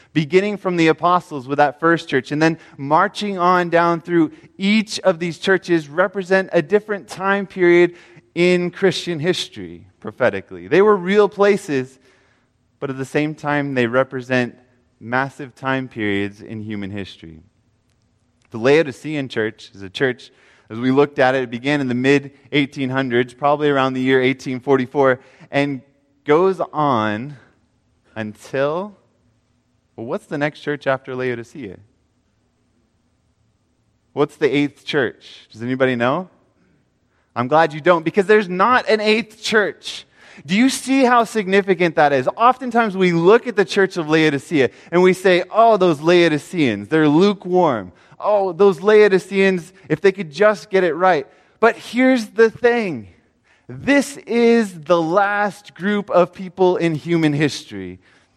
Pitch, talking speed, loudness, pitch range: 155 Hz, 145 wpm, -18 LUFS, 130-190 Hz